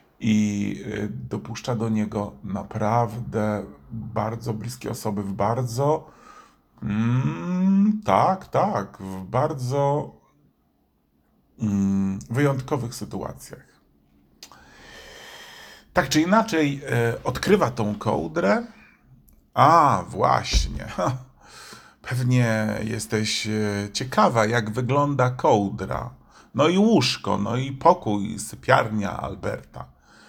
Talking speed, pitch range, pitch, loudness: 80 wpm, 105-130 Hz, 110 Hz, -23 LUFS